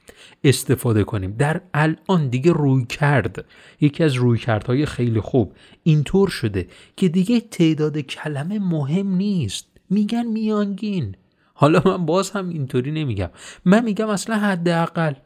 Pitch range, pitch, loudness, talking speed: 130-190 Hz, 155 Hz, -20 LUFS, 130 wpm